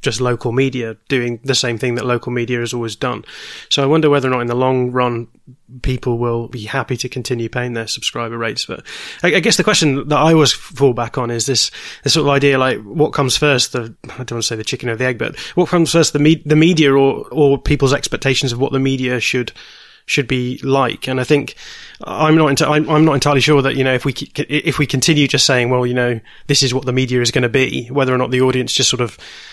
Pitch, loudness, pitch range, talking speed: 130 Hz, -15 LUFS, 125-145 Hz, 255 wpm